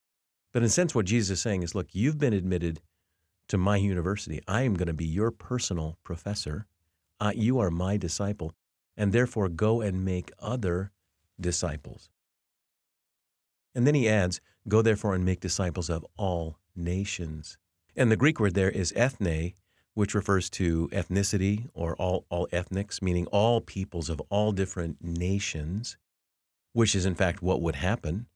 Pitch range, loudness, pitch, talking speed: 85-105 Hz, -28 LUFS, 95 Hz, 165 wpm